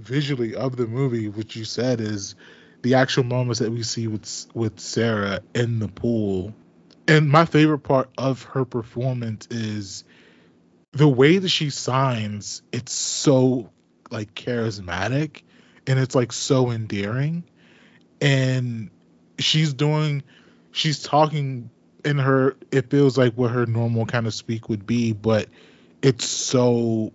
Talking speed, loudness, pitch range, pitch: 140 wpm, -22 LUFS, 110-135 Hz, 120 Hz